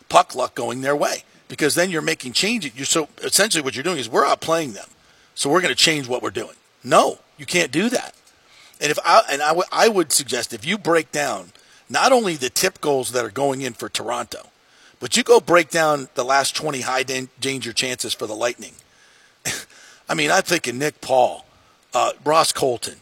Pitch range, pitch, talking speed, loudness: 130-165 Hz, 145 Hz, 210 wpm, -20 LUFS